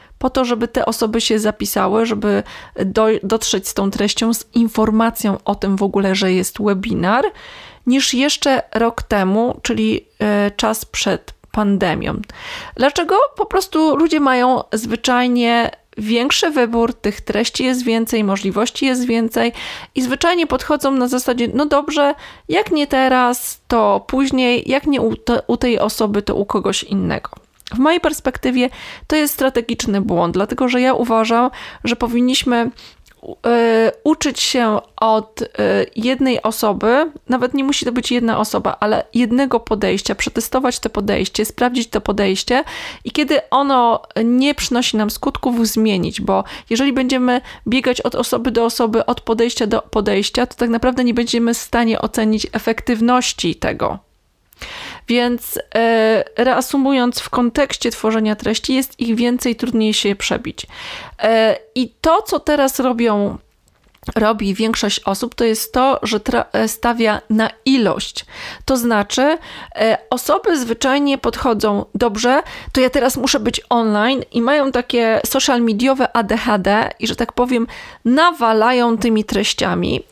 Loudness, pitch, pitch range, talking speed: -17 LUFS, 240 Hz, 220-260 Hz, 140 wpm